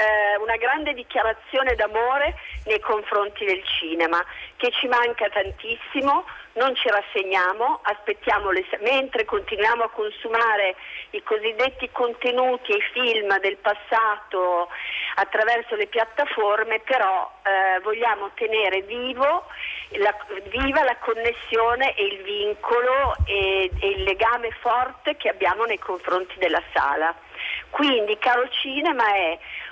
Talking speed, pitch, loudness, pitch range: 115 wpm, 230 Hz, -22 LUFS, 205-265 Hz